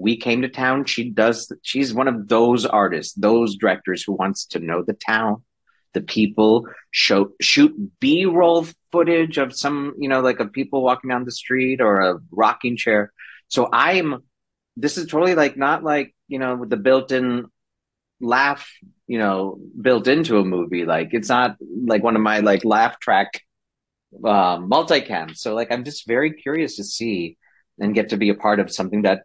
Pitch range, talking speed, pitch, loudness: 105-140 Hz, 185 wpm, 120 Hz, -19 LUFS